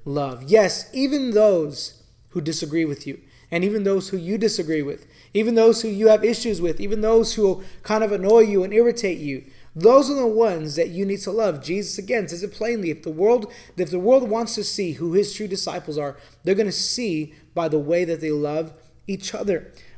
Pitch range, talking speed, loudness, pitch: 160-220 Hz, 220 wpm, -21 LUFS, 195 Hz